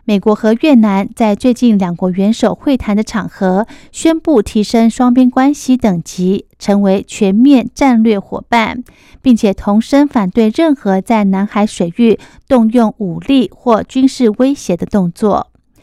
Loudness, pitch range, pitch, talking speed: -12 LUFS, 200-250 Hz, 220 Hz, 225 characters per minute